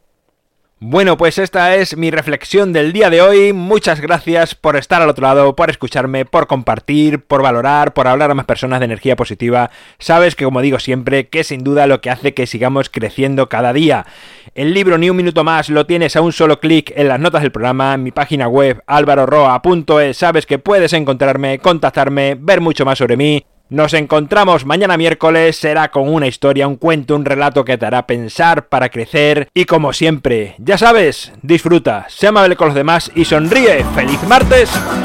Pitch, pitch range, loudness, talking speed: 150 Hz, 135-165 Hz, -12 LUFS, 195 wpm